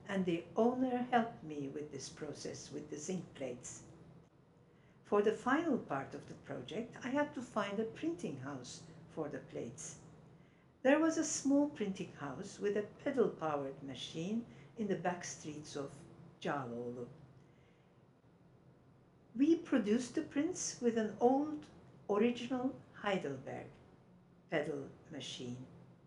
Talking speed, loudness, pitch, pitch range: 130 wpm, -38 LUFS, 165 Hz, 150-235 Hz